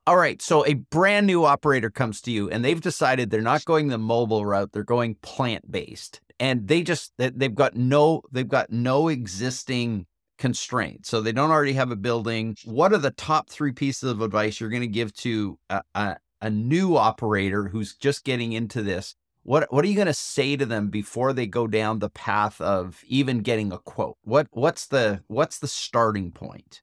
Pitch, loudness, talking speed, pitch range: 120 Hz, -24 LUFS, 205 wpm, 110-140 Hz